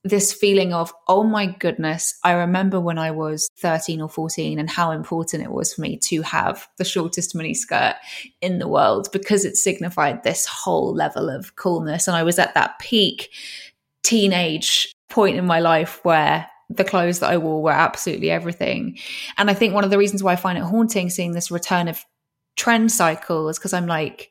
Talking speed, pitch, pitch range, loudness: 200 wpm, 175 Hz, 160-195 Hz, -20 LUFS